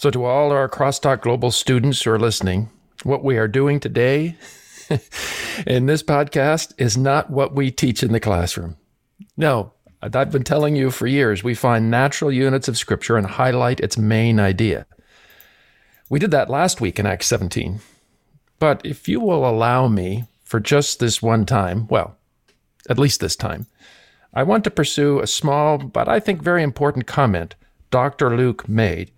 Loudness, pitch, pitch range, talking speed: -19 LUFS, 125 Hz, 110-145 Hz, 170 wpm